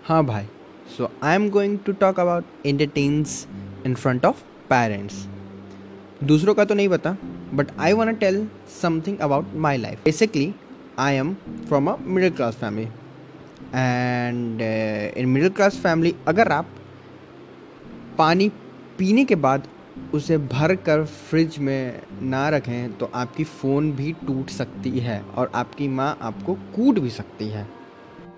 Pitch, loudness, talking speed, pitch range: 145 Hz, -22 LUFS, 145 wpm, 120-175 Hz